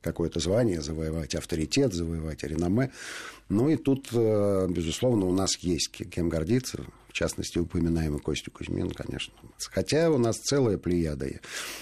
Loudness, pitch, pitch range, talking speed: -28 LUFS, 90 Hz, 80-115 Hz, 130 wpm